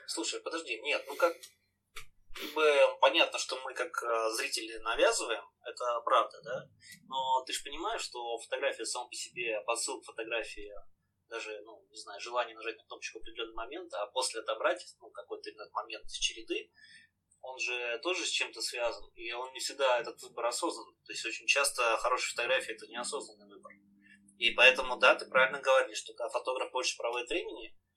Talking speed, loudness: 170 wpm, -32 LUFS